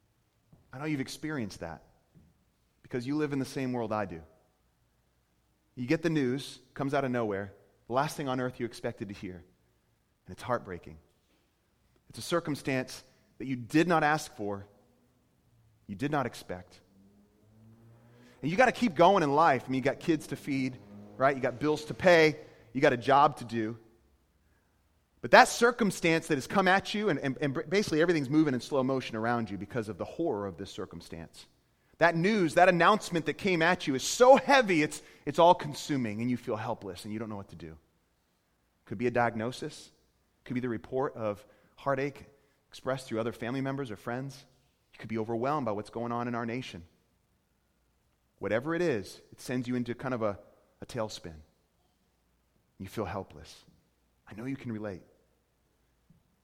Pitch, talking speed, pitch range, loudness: 120 Hz, 185 wpm, 100-145 Hz, -29 LUFS